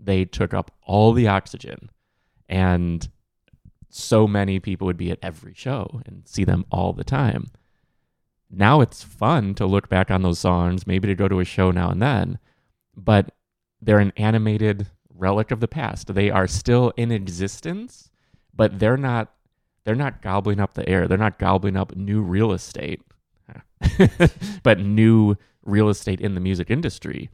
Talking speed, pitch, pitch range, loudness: 165 wpm, 100 Hz, 95-110 Hz, -21 LUFS